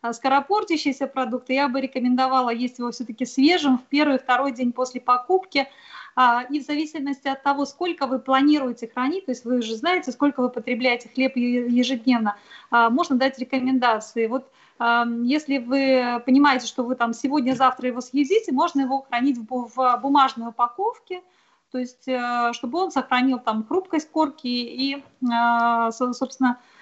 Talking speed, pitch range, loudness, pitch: 140 wpm, 245-280 Hz, -22 LUFS, 260 Hz